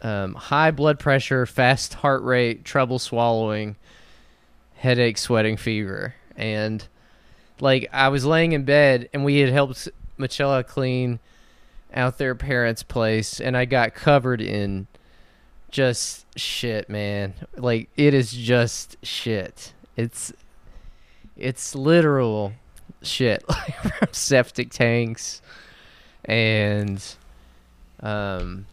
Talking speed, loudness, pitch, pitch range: 105 wpm, -22 LUFS, 120 Hz, 105-135 Hz